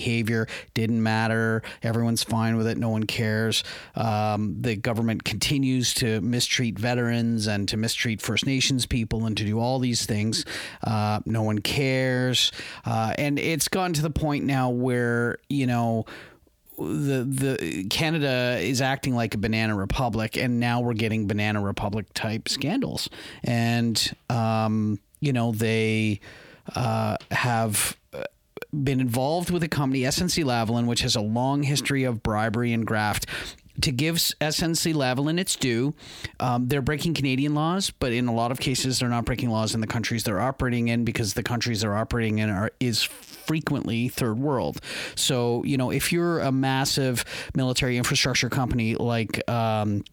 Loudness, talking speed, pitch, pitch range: -25 LUFS, 160 wpm, 120 Hz, 110-135 Hz